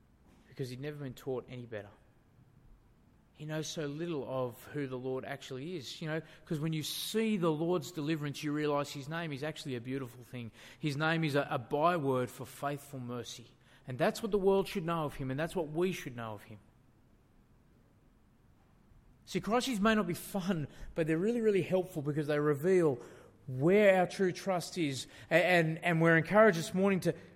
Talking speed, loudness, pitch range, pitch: 195 wpm, -33 LUFS, 130-175 Hz, 150 Hz